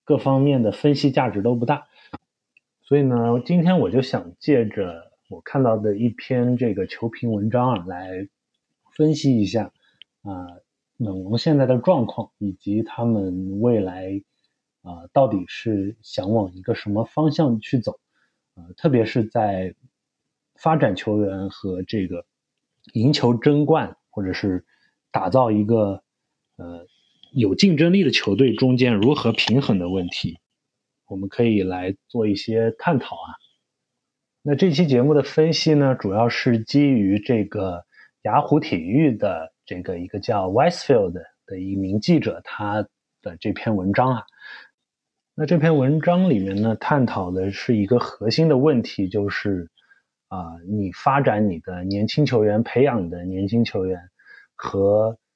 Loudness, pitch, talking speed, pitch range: -21 LUFS, 110 Hz, 225 characters per minute, 95-130 Hz